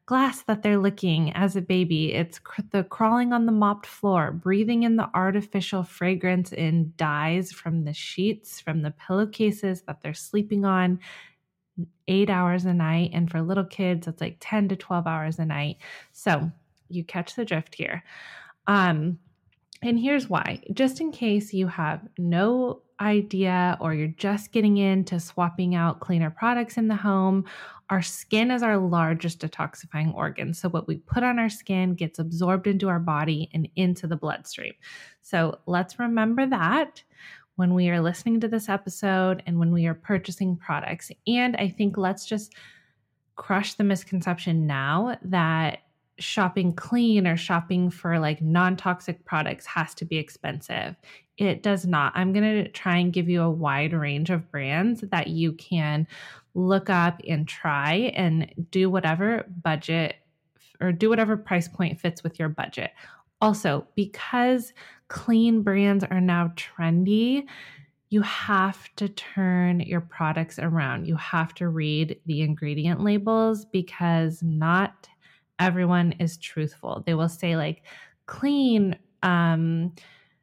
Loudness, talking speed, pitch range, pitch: -25 LUFS, 155 wpm, 165-200 Hz, 180 Hz